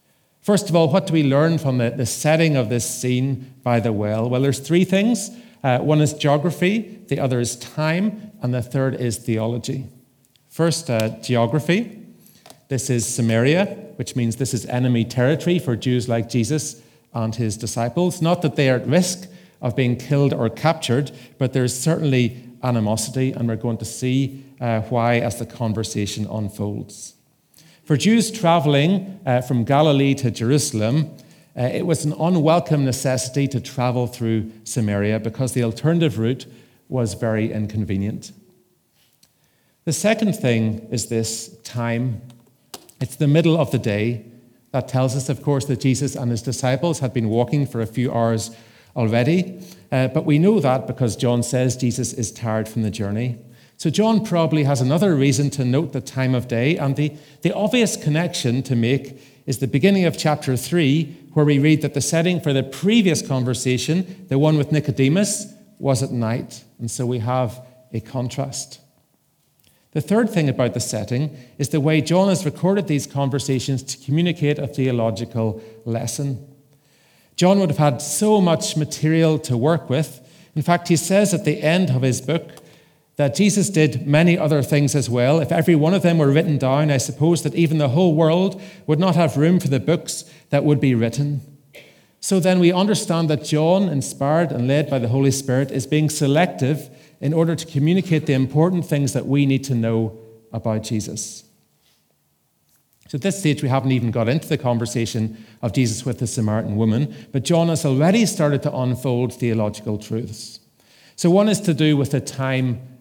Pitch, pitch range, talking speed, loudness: 135 Hz, 120-160 Hz, 175 wpm, -20 LUFS